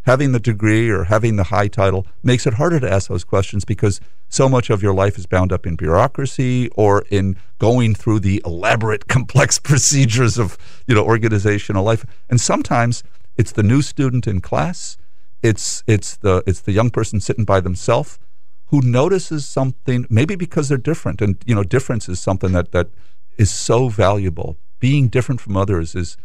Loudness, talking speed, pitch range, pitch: -17 LUFS, 185 wpm, 95-125 Hz, 110 Hz